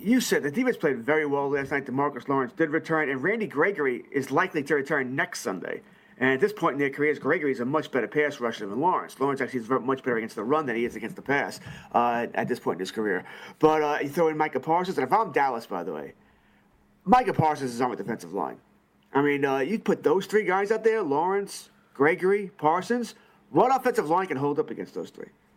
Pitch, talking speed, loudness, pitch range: 150 Hz, 240 wpm, -26 LUFS, 130-185 Hz